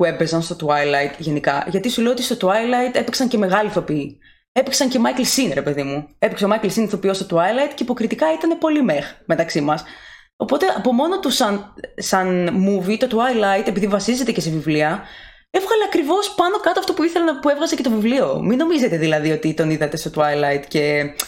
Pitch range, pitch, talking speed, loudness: 160-260 Hz, 205 Hz, 195 wpm, -19 LUFS